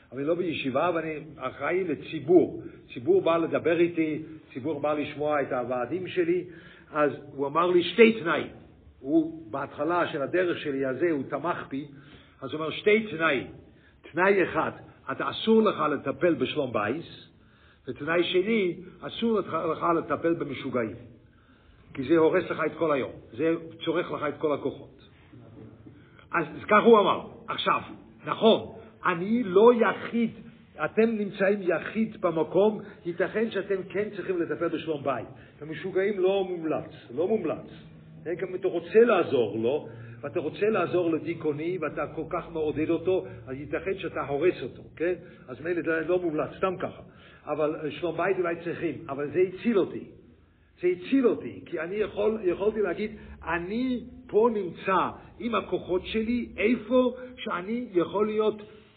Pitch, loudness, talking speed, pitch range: 170 Hz, -27 LUFS, 150 wpm, 150-195 Hz